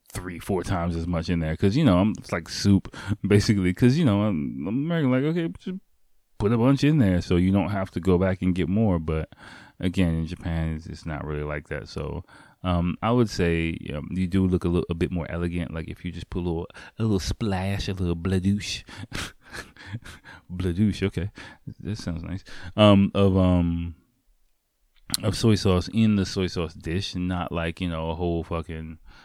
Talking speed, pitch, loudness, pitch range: 205 wpm, 95 Hz, -25 LUFS, 85-105 Hz